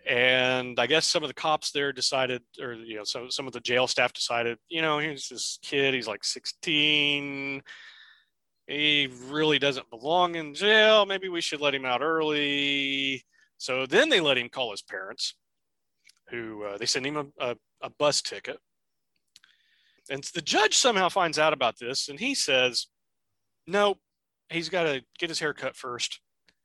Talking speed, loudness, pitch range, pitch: 180 wpm, -26 LUFS, 125-160 Hz, 140 Hz